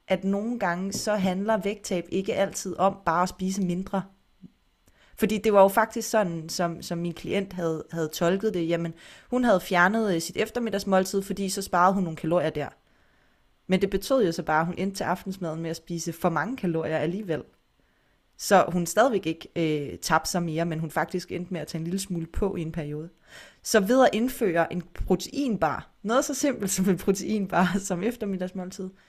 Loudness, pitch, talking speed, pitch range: -26 LUFS, 185 Hz, 195 wpm, 170-200 Hz